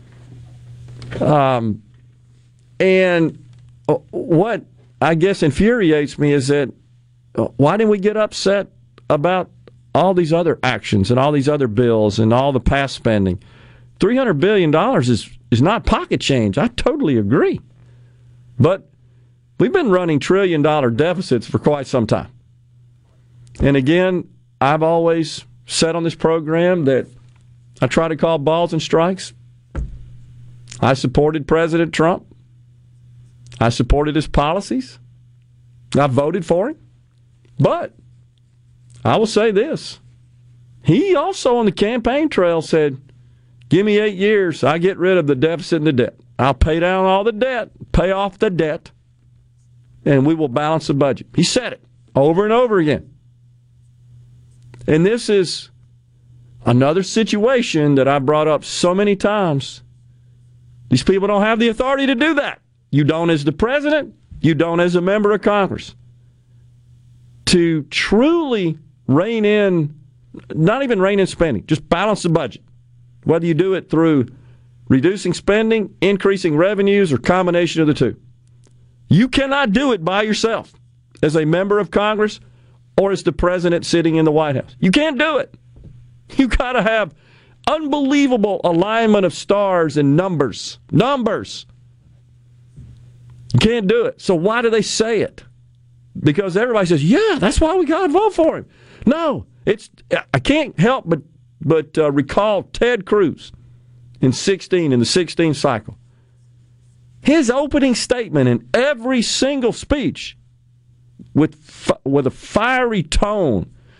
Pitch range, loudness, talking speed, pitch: 120-190 Hz, -17 LUFS, 145 wpm, 145 Hz